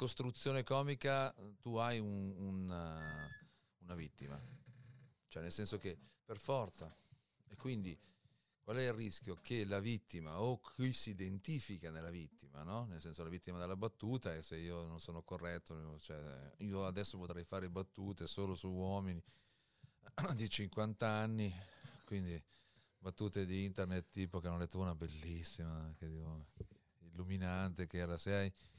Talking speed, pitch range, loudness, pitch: 150 wpm, 85-110 Hz, -44 LUFS, 95 Hz